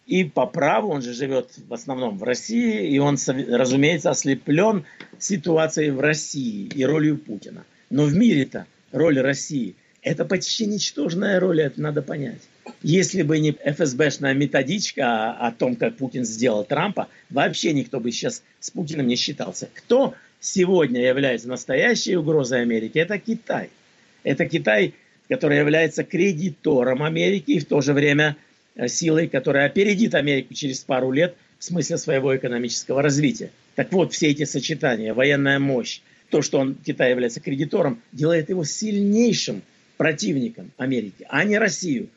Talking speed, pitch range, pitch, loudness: 145 wpm, 135-175 Hz, 150 Hz, -22 LUFS